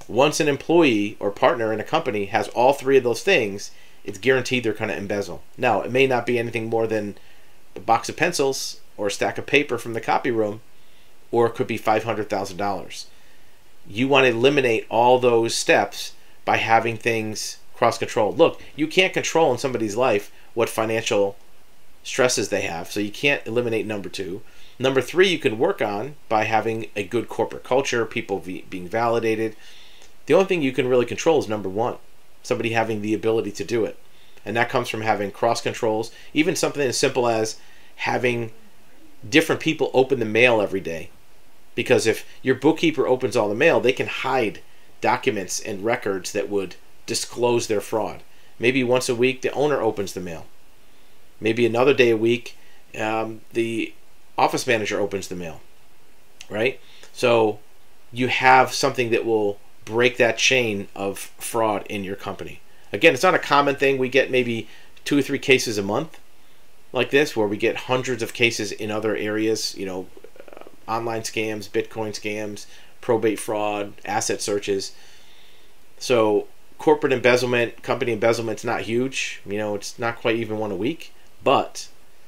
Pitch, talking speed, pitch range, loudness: 115 Hz, 170 wpm, 105-130 Hz, -22 LUFS